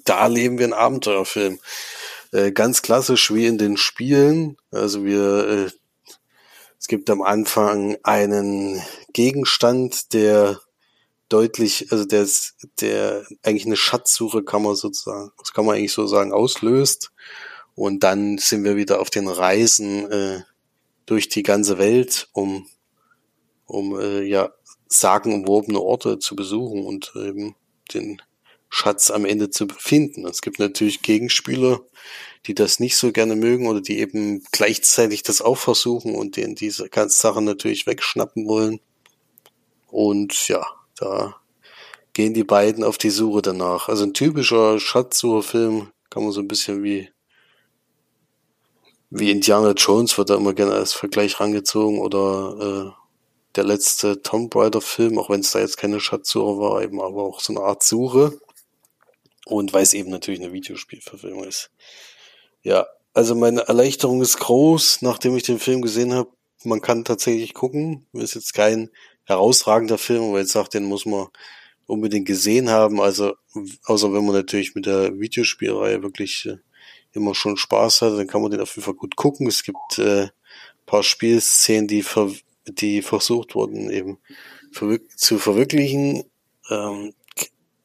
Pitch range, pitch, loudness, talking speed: 100-115 Hz, 105 Hz, -19 LUFS, 150 wpm